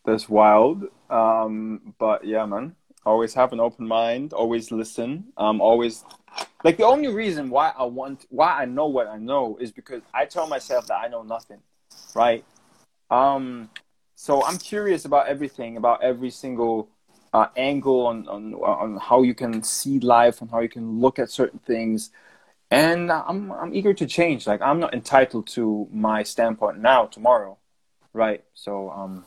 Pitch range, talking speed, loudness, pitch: 110-135 Hz, 170 wpm, -22 LUFS, 115 Hz